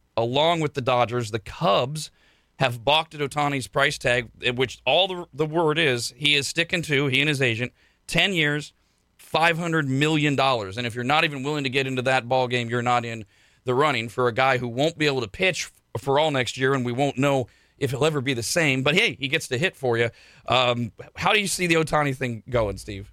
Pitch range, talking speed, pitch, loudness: 120-150 Hz, 230 wpm, 135 Hz, -23 LUFS